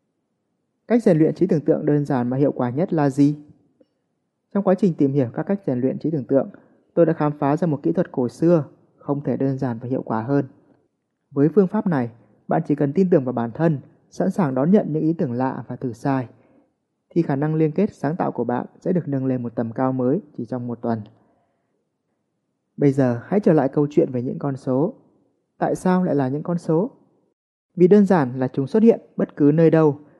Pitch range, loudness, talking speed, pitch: 130-175 Hz, -21 LUFS, 235 wpm, 145 Hz